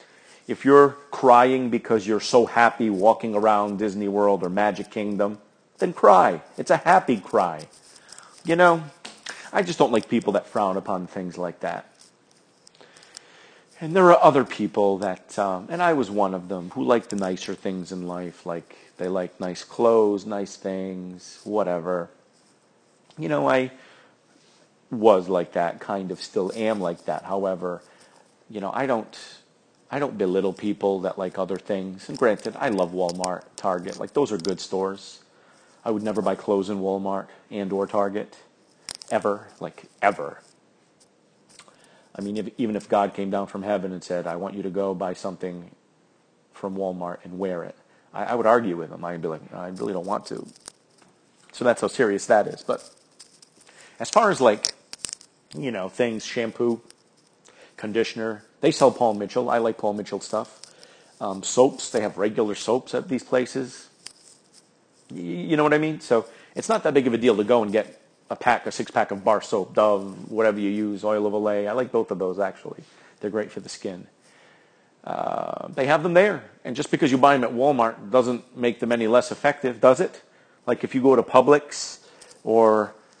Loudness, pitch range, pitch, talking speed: -23 LUFS, 95-120 Hz, 105 Hz, 185 wpm